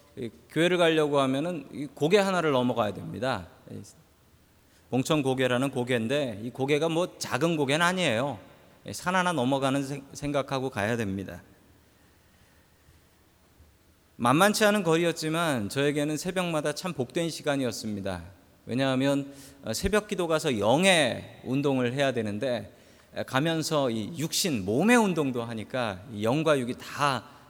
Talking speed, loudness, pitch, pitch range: 275 characters per minute, -27 LUFS, 135 Hz, 105-155 Hz